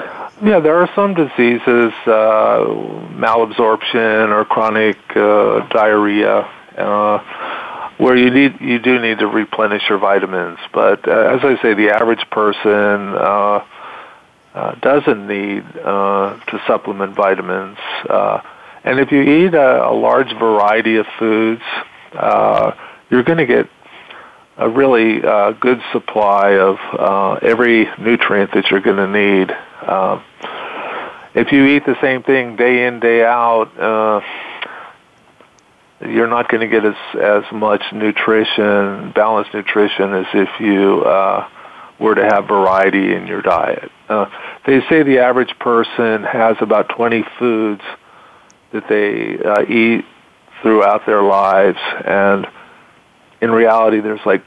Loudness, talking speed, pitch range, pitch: -14 LUFS, 135 wpm, 105-120 Hz, 110 Hz